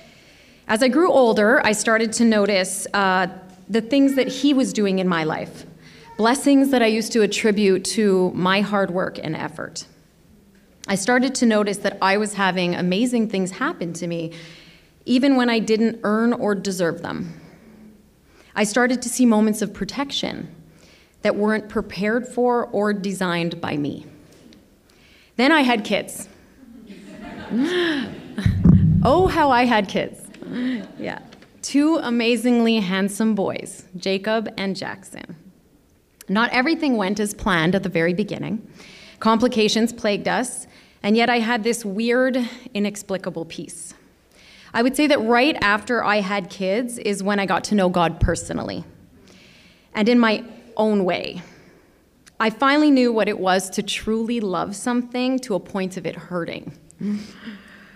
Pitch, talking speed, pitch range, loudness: 215 Hz, 145 wpm, 190-240 Hz, -20 LUFS